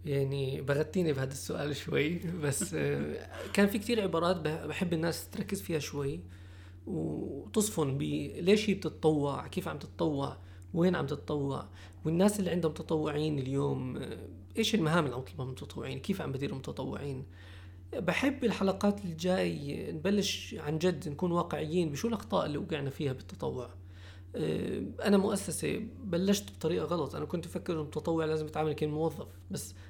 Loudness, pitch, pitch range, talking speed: -33 LUFS, 155 Hz, 130-180 Hz, 135 wpm